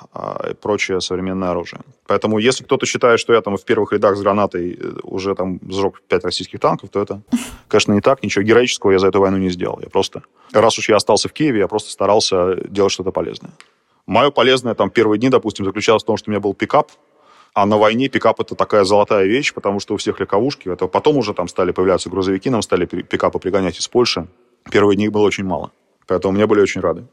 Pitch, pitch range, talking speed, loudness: 100 Hz, 95-105 Hz, 220 wpm, -17 LUFS